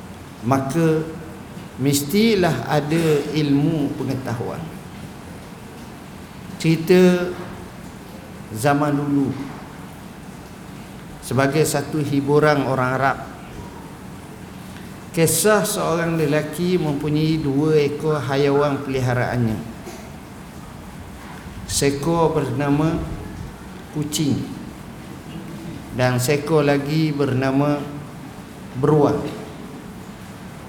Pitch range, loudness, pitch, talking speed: 140-160 Hz, -20 LUFS, 145 Hz, 55 wpm